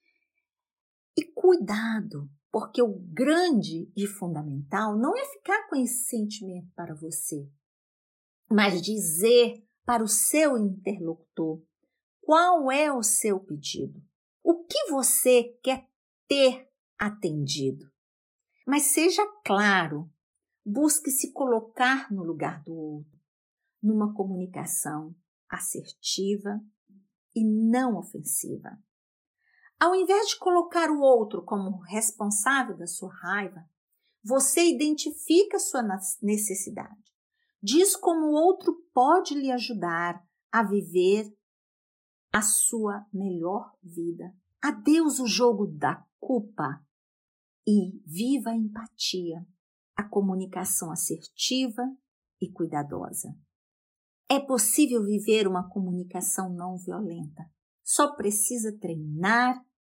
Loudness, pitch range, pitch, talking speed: -26 LUFS, 185-270 Hz, 215 Hz, 100 wpm